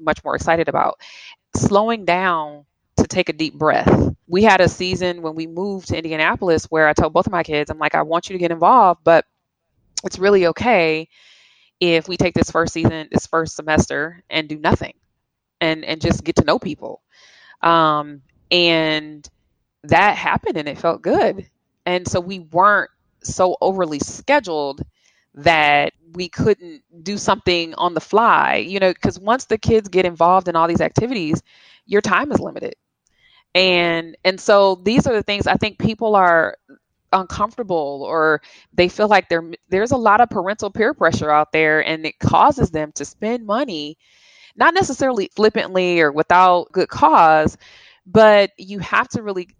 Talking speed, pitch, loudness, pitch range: 170 wpm, 175 Hz, -17 LUFS, 155-200 Hz